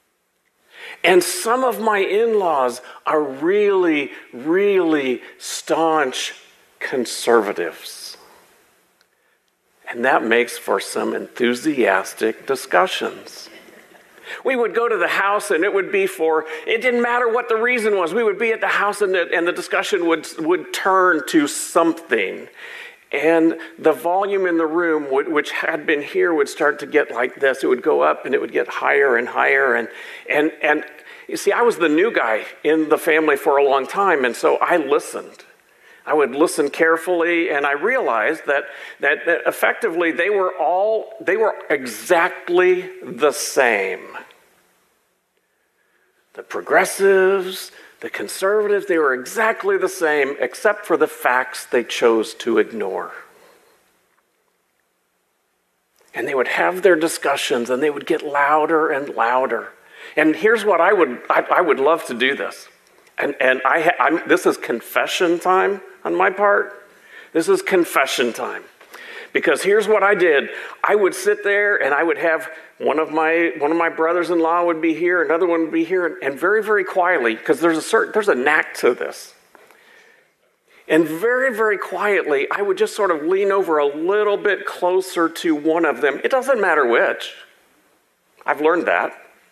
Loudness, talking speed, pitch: -18 LUFS, 165 wpm, 215 Hz